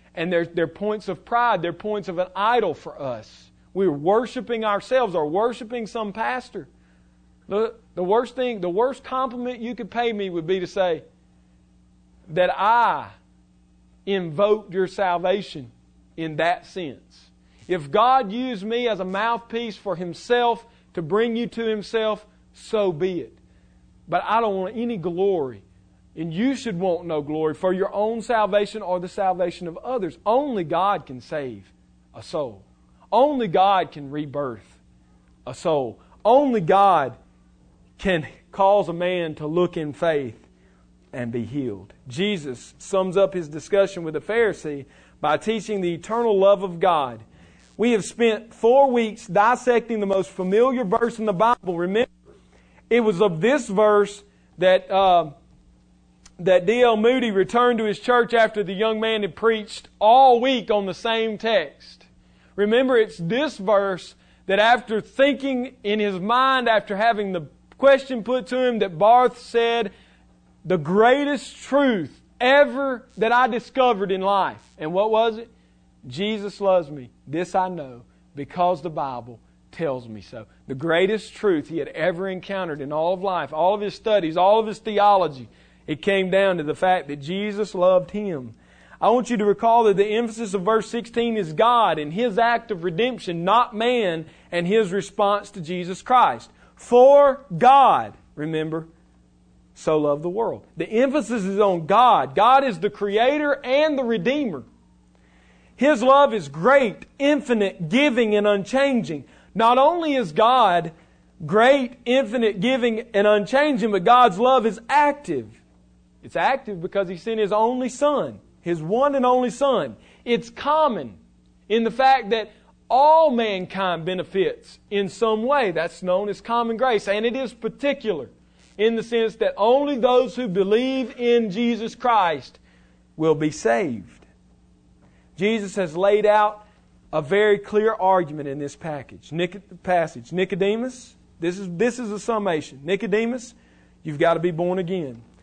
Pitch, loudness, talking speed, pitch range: 200 Hz, -21 LUFS, 155 wpm, 165-235 Hz